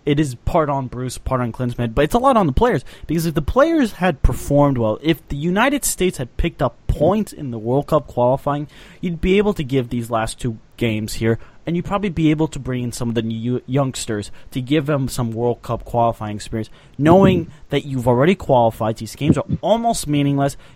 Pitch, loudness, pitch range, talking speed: 135 Hz, -19 LUFS, 120-165 Hz, 220 wpm